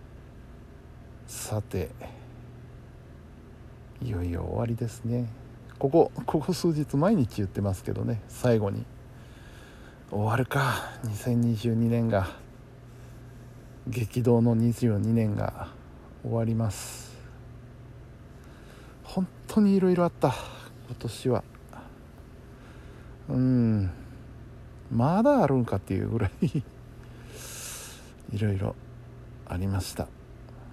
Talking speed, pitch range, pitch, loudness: 165 characters per minute, 115-125 Hz, 120 Hz, -28 LUFS